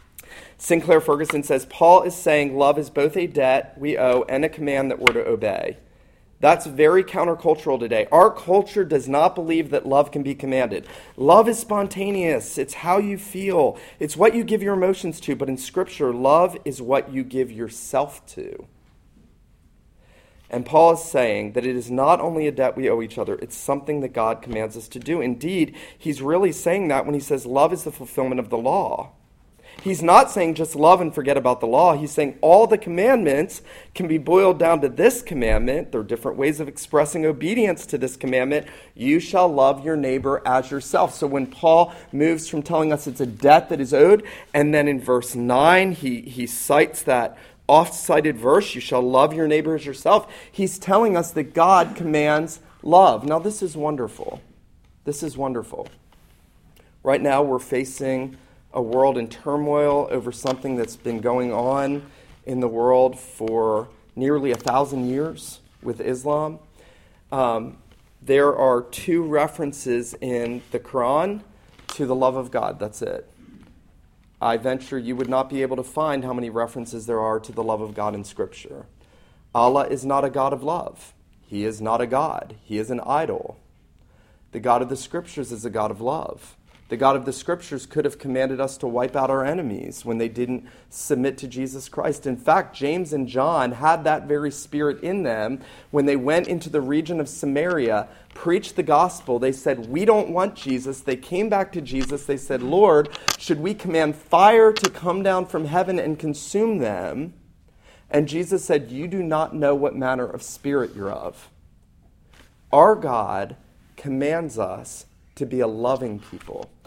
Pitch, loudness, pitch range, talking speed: 145 Hz, -21 LUFS, 130-165 Hz, 185 wpm